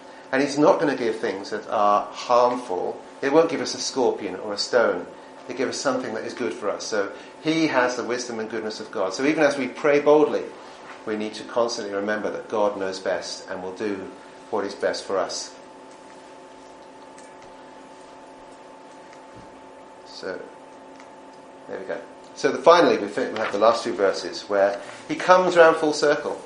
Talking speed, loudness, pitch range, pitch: 180 wpm, -23 LUFS, 105-155 Hz, 125 Hz